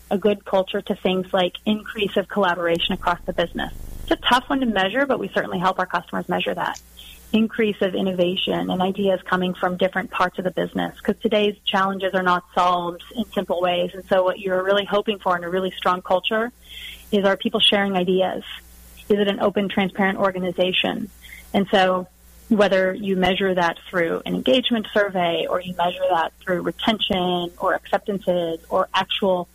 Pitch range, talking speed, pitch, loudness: 180-205 Hz, 185 wpm, 190 Hz, -21 LUFS